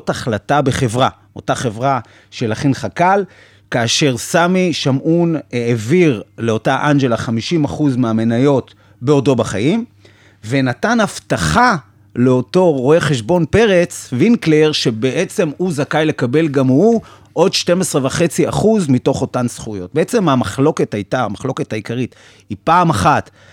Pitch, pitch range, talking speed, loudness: 135 Hz, 115-160 Hz, 110 wpm, -15 LUFS